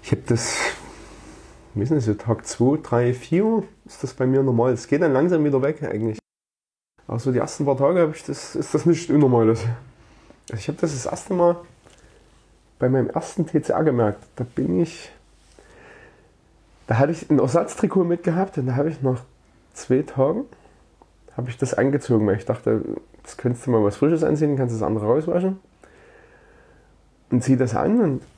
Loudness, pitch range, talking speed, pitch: -22 LUFS, 120-165 Hz, 175 wpm, 135 Hz